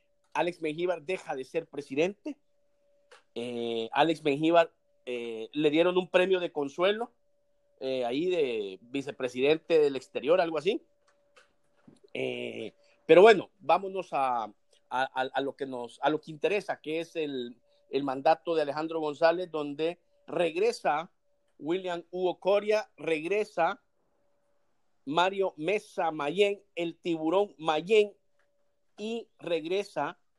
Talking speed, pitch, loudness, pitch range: 120 wpm, 175 Hz, -29 LUFS, 150-215 Hz